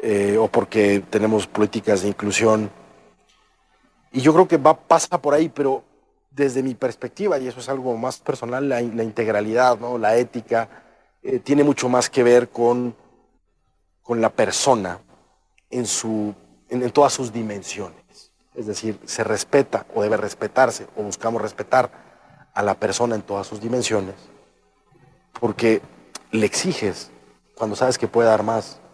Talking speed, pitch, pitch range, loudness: 155 wpm, 115 Hz, 105-130 Hz, -21 LUFS